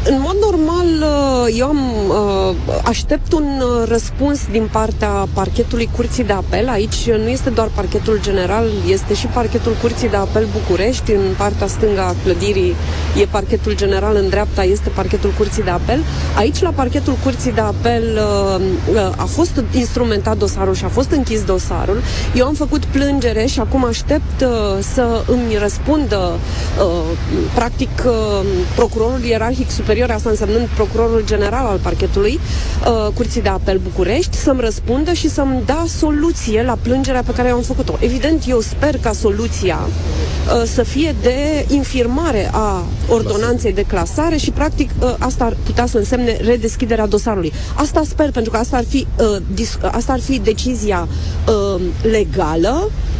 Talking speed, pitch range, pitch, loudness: 155 wpm, 205-275 Hz, 235 Hz, -16 LUFS